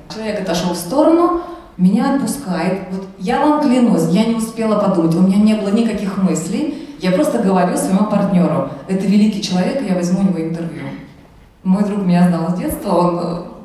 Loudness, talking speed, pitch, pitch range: -16 LUFS, 175 wpm, 195 Hz, 180-225 Hz